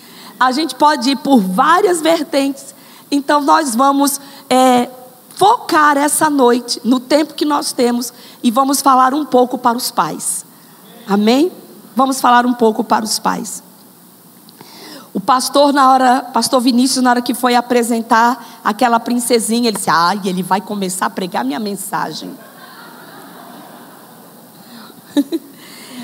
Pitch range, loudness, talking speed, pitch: 235-280 Hz, -14 LUFS, 135 wpm, 250 Hz